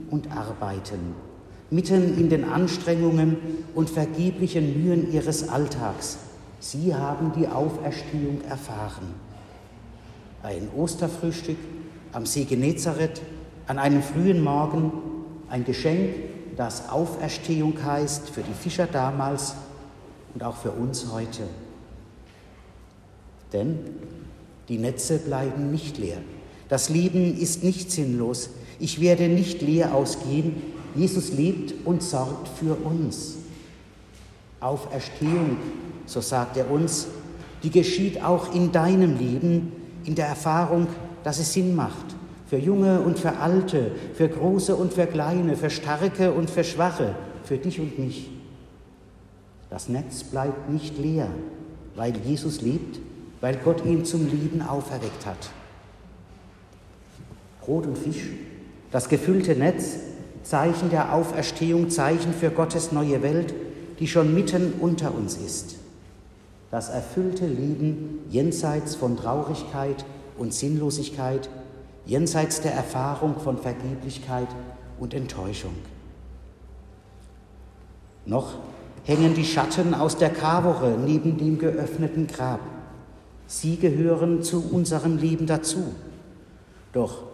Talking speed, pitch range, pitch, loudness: 115 wpm, 125-165 Hz, 150 Hz, -25 LUFS